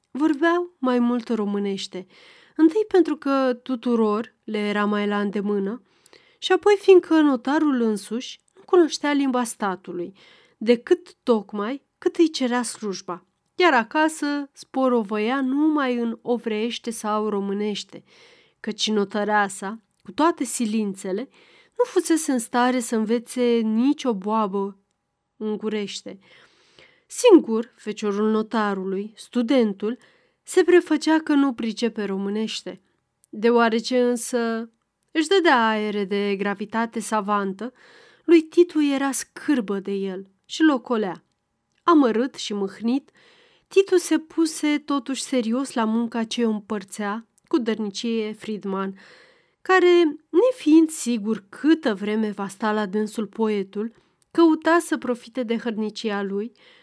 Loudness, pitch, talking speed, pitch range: -22 LUFS, 235 Hz, 115 wpm, 210-305 Hz